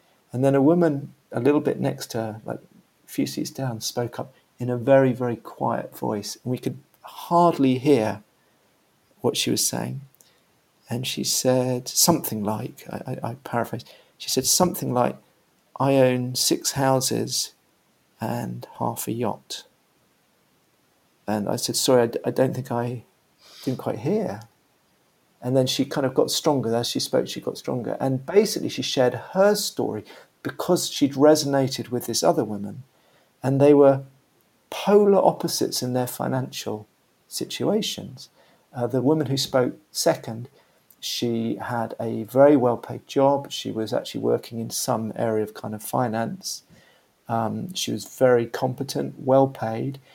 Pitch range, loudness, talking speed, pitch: 115-140 Hz, -23 LUFS, 160 wpm, 130 Hz